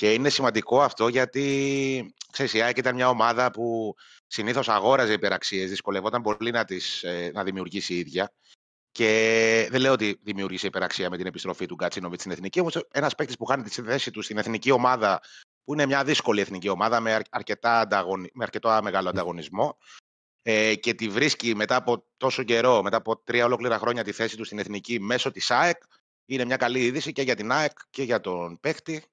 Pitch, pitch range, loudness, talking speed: 115 Hz, 100-125 Hz, -25 LUFS, 185 wpm